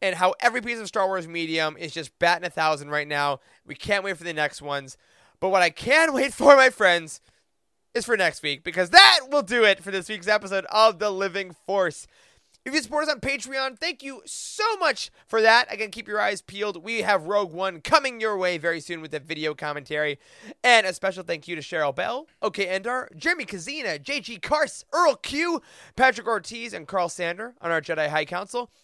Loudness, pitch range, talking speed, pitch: -23 LUFS, 170-245 Hz, 215 wpm, 195 Hz